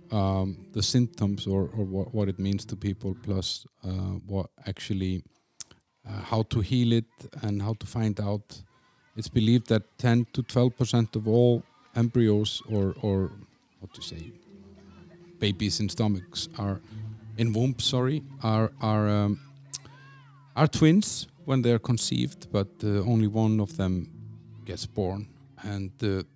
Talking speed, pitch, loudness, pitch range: 150 wpm, 110 Hz, -27 LUFS, 100-120 Hz